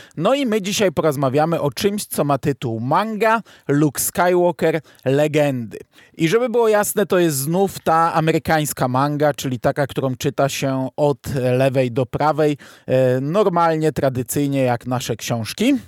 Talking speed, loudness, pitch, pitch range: 145 wpm, -19 LUFS, 150 Hz, 135-175 Hz